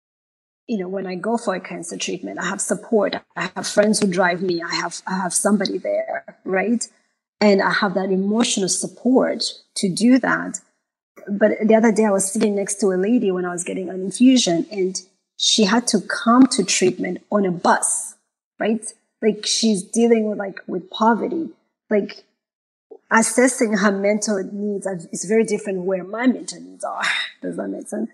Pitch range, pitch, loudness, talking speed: 190-225 Hz, 210 Hz, -20 LUFS, 185 wpm